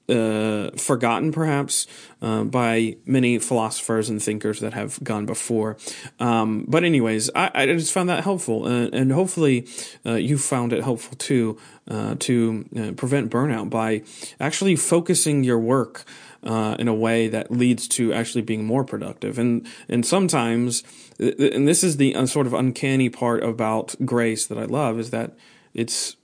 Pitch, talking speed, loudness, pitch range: 120 Hz, 160 wpm, -22 LUFS, 110-135 Hz